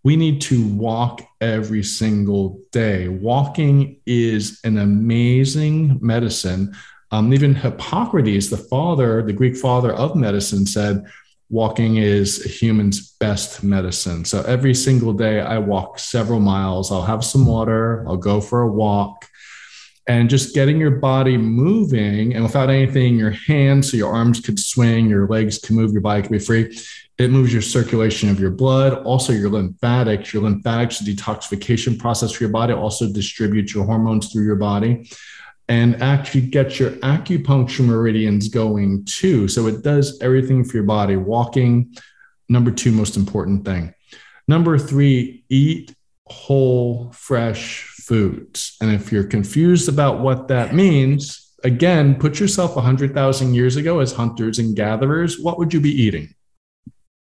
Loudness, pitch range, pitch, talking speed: -18 LUFS, 105-130 Hz, 115 Hz, 155 wpm